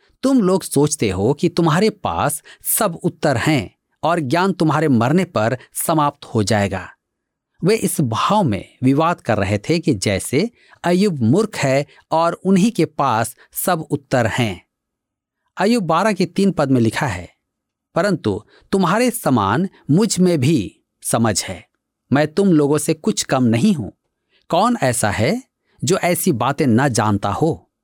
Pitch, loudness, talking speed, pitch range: 155 Hz, -18 LUFS, 155 wpm, 120-180 Hz